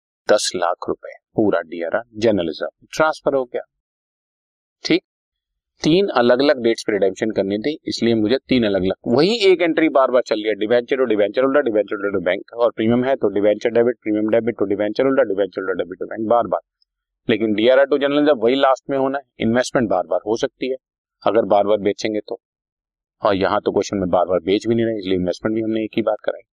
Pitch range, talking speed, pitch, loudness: 105-135 Hz, 190 wpm, 115 Hz, -19 LUFS